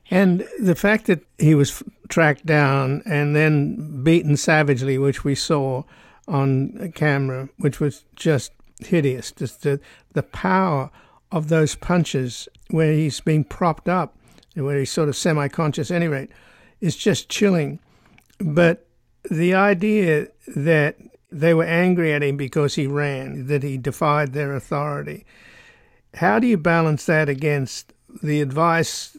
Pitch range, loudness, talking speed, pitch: 140-170 Hz, -20 LUFS, 145 wpm, 155 Hz